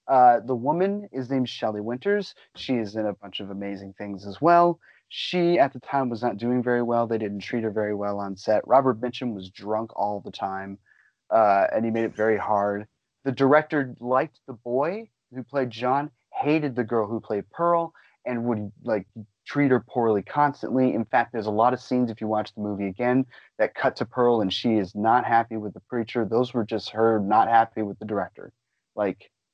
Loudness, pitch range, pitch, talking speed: -25 LUFS, 105-130 Hz, 120 Hz, 210 wpm